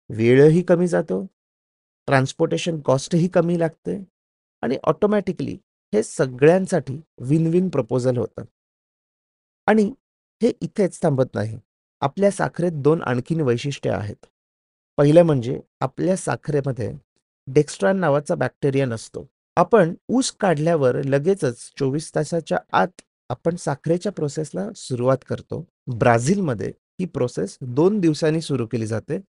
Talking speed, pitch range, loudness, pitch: 110 wpm, 125-175 Hz, -21 LUFS, 150 Hz